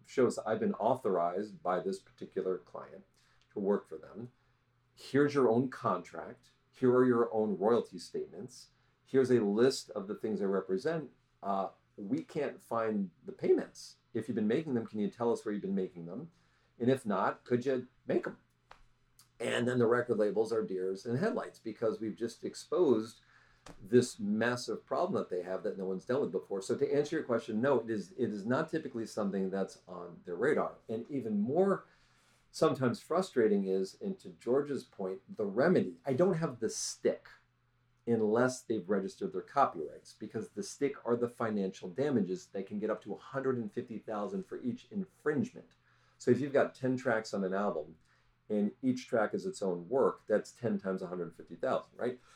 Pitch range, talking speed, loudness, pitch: 95-130 Hz, 190 wpm, -34 LUFS, 115 Hz